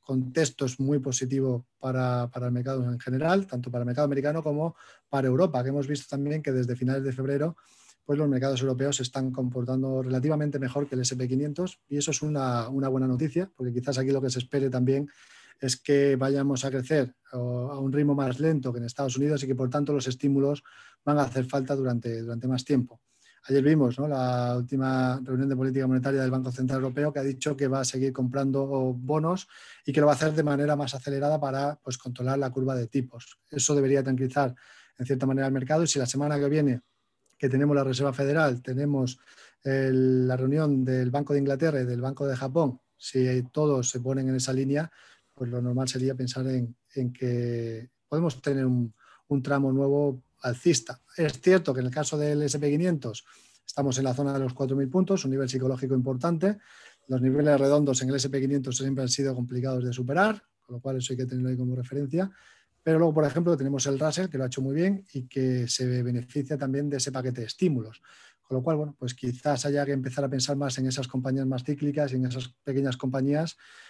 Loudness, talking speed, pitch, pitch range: -27 LUFS, 215 wpm, 135 Hz, 130-145 Hz